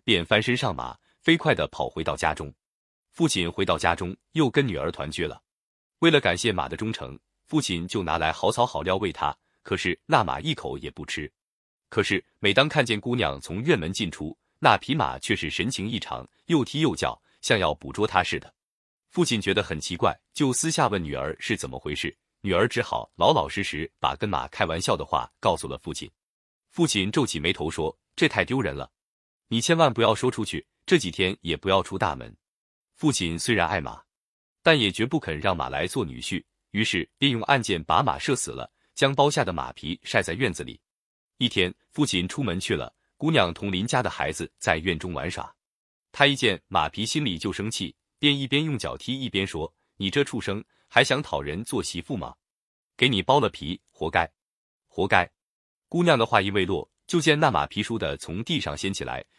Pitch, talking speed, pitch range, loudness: 110 Hz, 280 characters per minute, 90-140 Hz, -25 LUFS